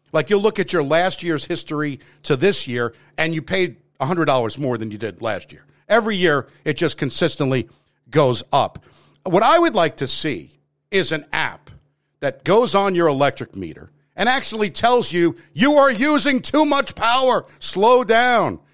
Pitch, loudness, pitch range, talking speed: 170 Hz, -19 LUFS, 145-225 Hz, 175 wpm